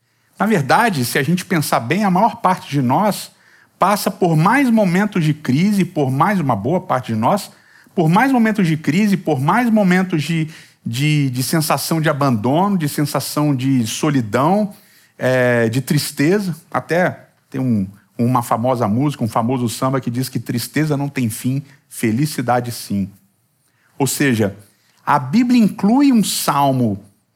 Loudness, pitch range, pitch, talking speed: -17 LUFS, 125-185 Hz, 145 Hz, 155 wpm